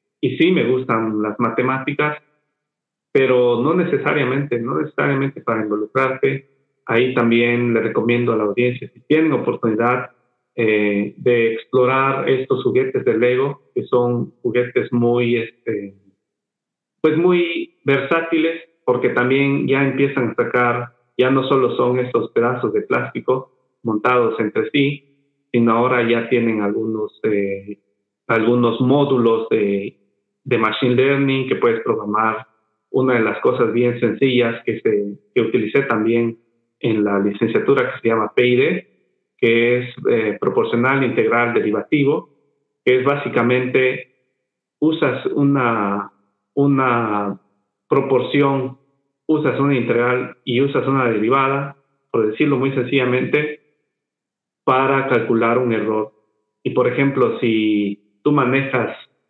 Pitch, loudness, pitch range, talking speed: 125 Hz, -18 LUFS, 115-140 Hz, 125 wpm